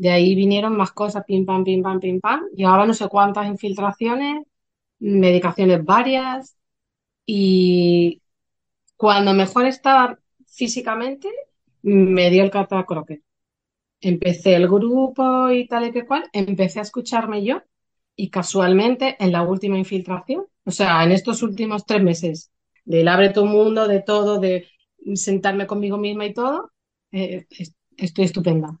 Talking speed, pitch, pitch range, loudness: 145 wpm, 200 Hz, 185-230 Hz, -19 LUFS